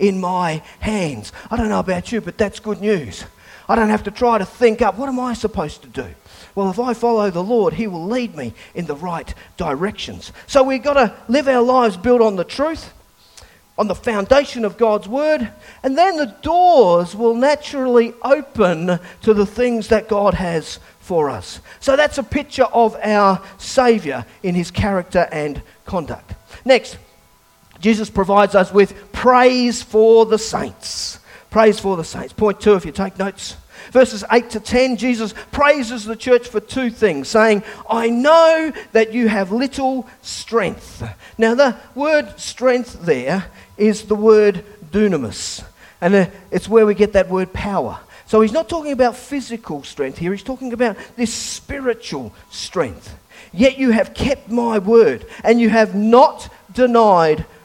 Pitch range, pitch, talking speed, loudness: 195-250 Hz, 225 Hz, 170 wpm, -17 LUFS